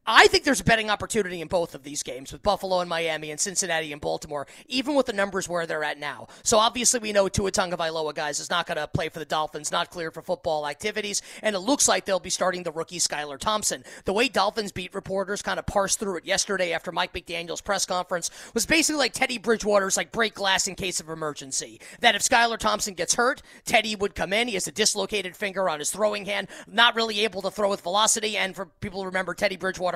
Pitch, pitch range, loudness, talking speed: 195 Hz, 170-215 Hz, -25 LUFS, 235 wpm